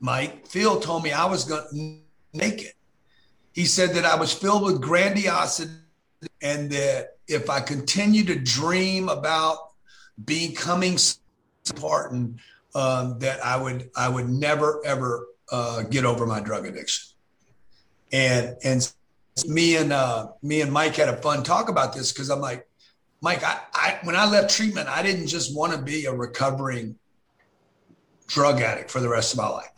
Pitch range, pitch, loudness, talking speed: 125-165 Hz, 145 Hz, -23 LUFS, 165 wpm